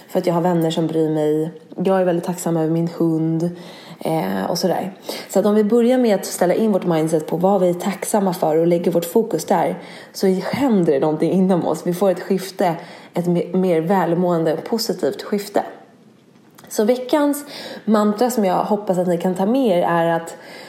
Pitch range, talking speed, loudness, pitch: 170-205 Hz, 200 wpm, -19 LUFS, 180 Hz